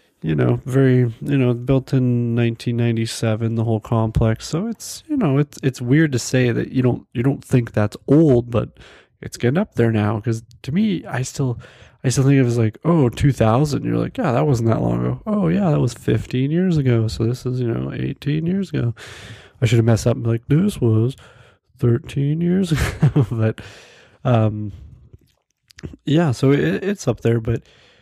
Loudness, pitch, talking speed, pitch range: -19 LUFS, 125 Hz, 205 wpm, 115-140 Hz